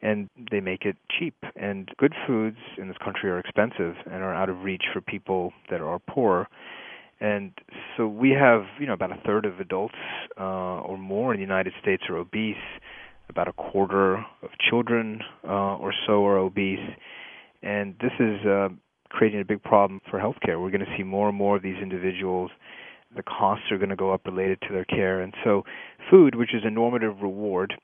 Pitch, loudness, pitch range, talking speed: 100 Hz, -25 LUFS, 95-105 Hz, 200 wpm